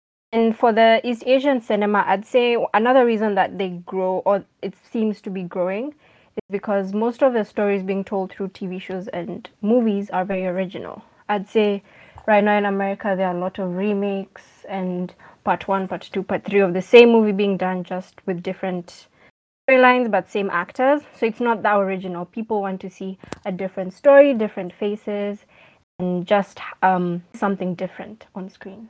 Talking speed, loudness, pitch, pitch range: 185 wpm, -20 LUFS, 200 Hz, 185-215 Hz